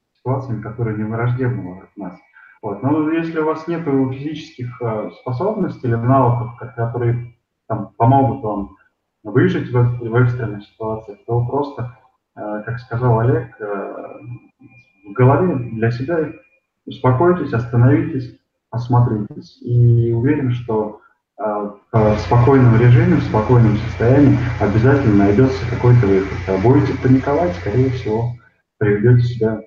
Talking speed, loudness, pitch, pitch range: 110 wpm, -17 LUFS, 120 Hz, 110-130 Hz